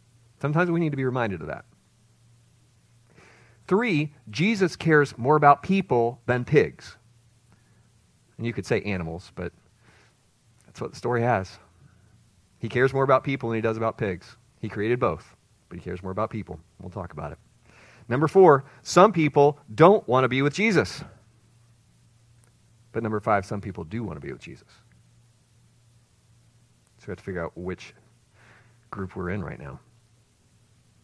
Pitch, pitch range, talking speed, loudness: 115 Hz, 110-125 Hz, 160 wpm, -24 LUFS